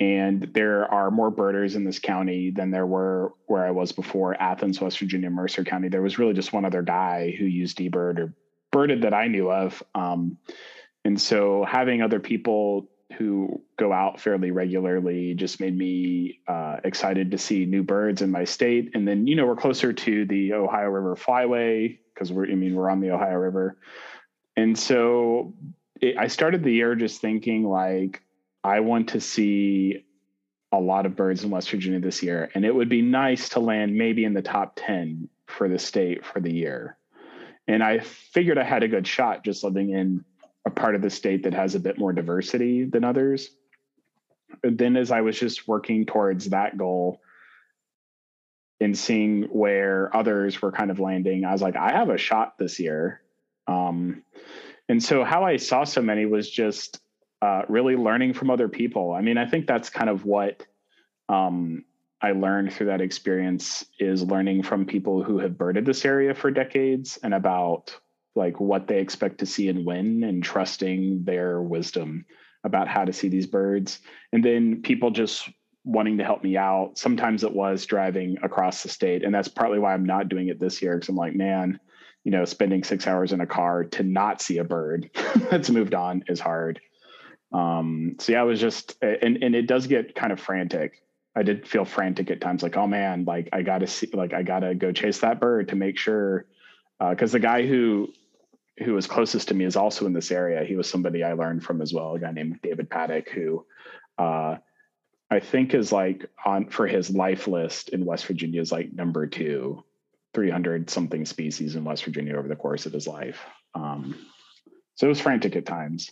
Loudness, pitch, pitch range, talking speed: -24 LUFS, 95 Hz, 90-110 Hz, 195 wpm